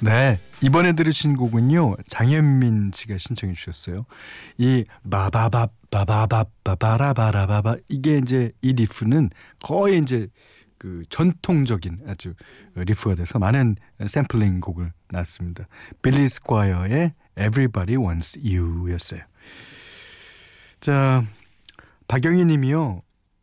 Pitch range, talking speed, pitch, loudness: 95-135 Hz, 265 characters per minute, 110 Hz, -21 LUFS